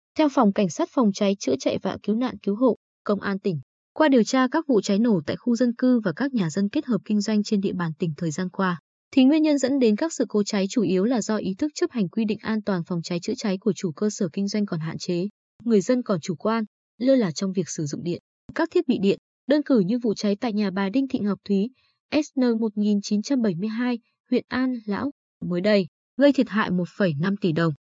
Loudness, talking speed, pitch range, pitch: -24 LUFS, 250 wpm, 195-250 Hz, 210 Hz